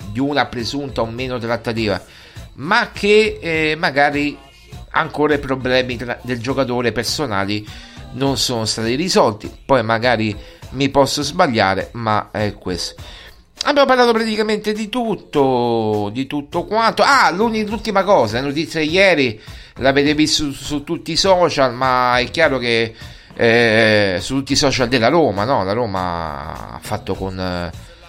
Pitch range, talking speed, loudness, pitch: 110-155 Hz, 145 wpm, -17 LUFS, 130 Hz